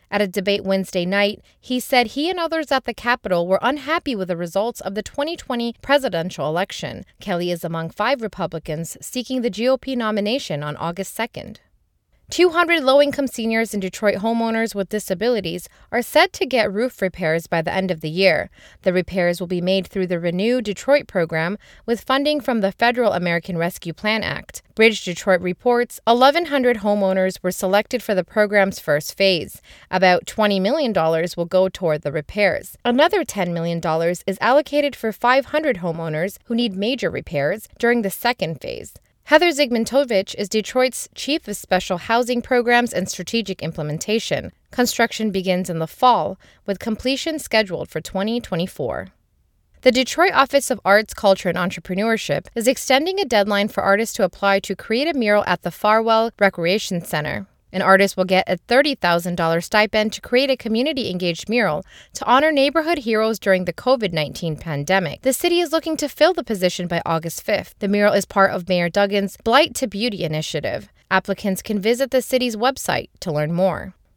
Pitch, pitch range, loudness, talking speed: 205 Hz, 180-245 Hz, -20 LUFS, 170 wpm